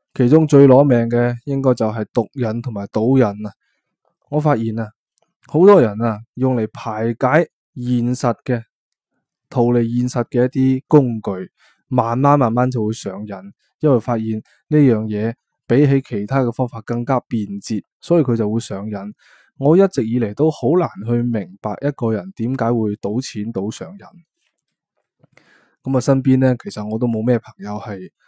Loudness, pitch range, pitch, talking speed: -18 LUFS, 110-135 Hz, 120 Hz, 235 characters per minute